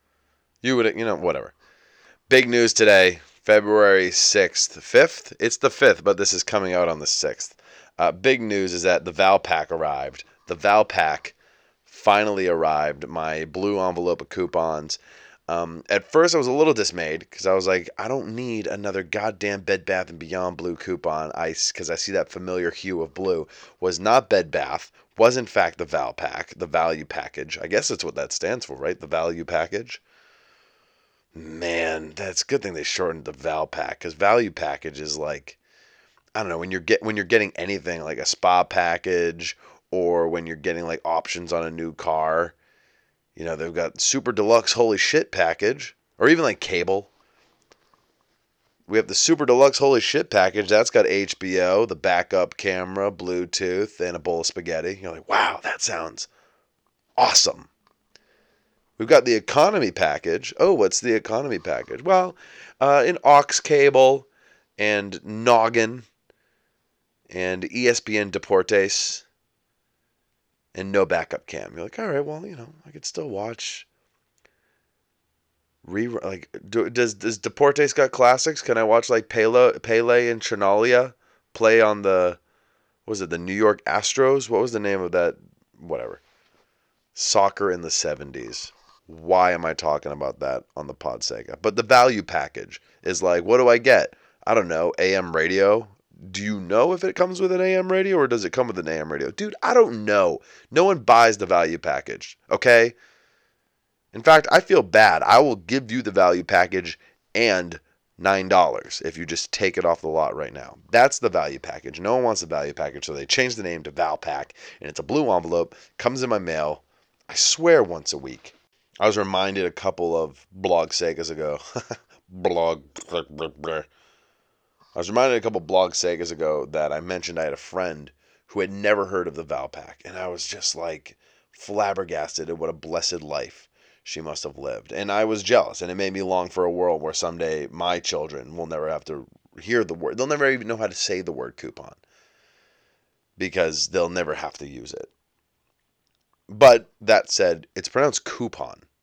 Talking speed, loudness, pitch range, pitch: 180 wpm, -21 LUFS, 85-125 Hz, 100 Hz